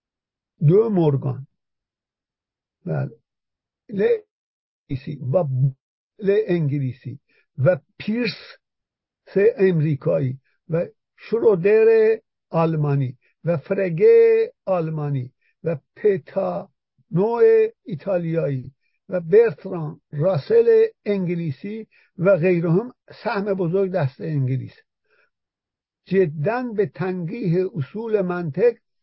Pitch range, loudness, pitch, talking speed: 145-220 Hz, -21 LUFS, 180 Hz, 75 wpm